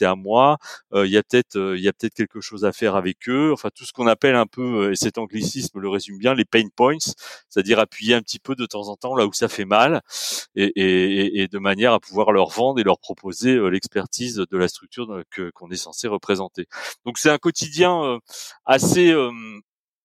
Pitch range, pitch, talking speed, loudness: 100-125 Hz, 110 Hz, 235 wpm, -20 LUFS